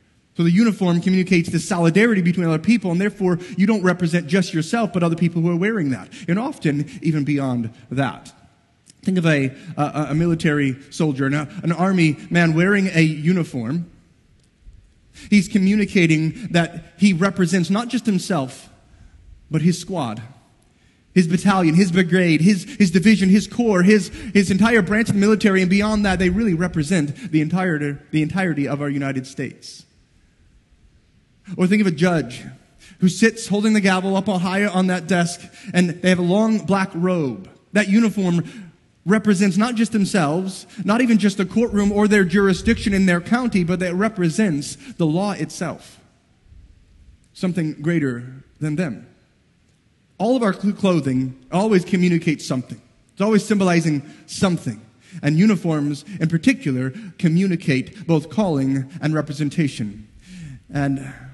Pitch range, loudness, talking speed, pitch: 155-200 Hz, -19 LUFS, 150 wpm, 180 Hz